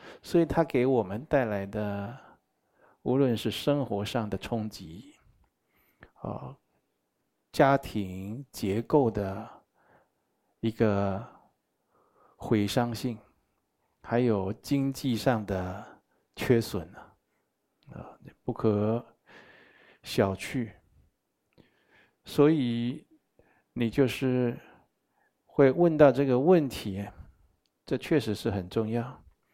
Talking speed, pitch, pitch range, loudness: 125 characters per minute, 115 Hz, 100-135 Hz, -28 LUFS